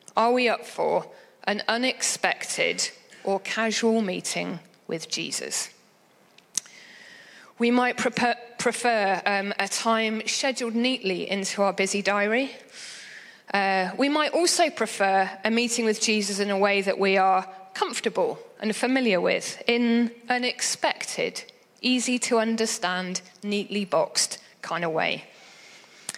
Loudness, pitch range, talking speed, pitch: -25 LUFS, 200-250 Hz, 120 wpm, 225 Hz